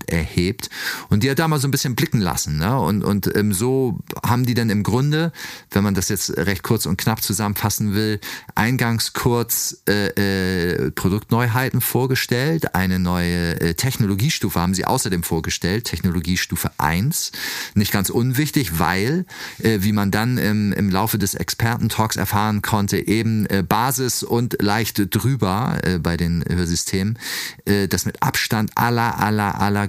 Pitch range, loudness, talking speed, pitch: 95-120 Hz, -20 LUFS, 155 wpm, 105 Hz